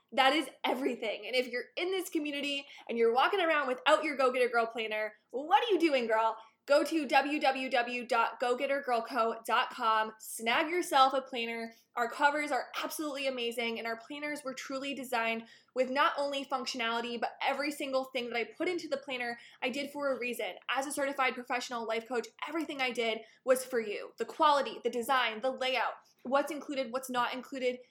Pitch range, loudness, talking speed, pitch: 235-285 Hz, -32 LUFS, 180 wpm, 260 Hz